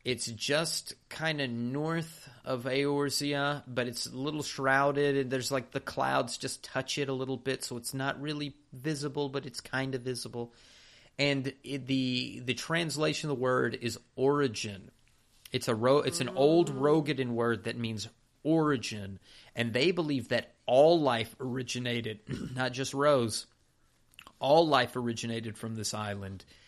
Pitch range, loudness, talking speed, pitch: 120-145 Hz, -31 LUFS, 155 wpm, 130 Hz